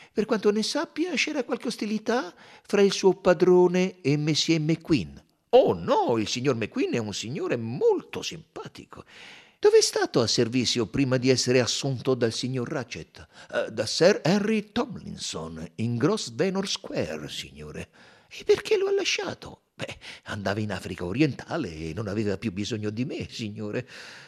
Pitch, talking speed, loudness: 150 Hz, 160 wpm, -25 LUFS